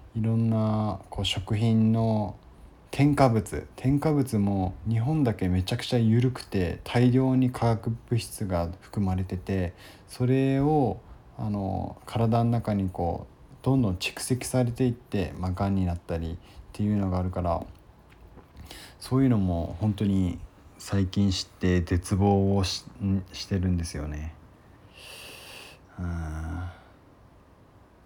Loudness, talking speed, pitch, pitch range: -27 LUFS, 240 characters per minute, 100 Hz, 90-115 Hz